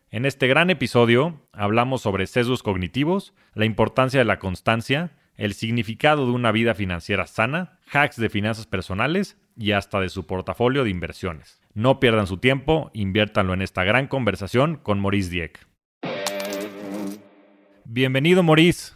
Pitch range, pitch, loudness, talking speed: 100-130 Hz, 110 Hz, -22 LUFS, 140 wpm